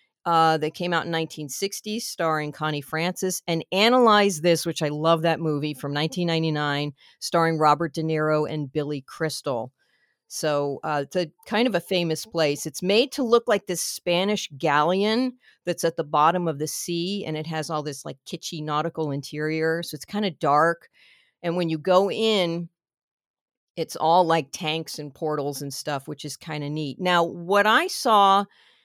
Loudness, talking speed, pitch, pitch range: -24 LUFS, 180 wpm, 165 Hz, 150-180 Hz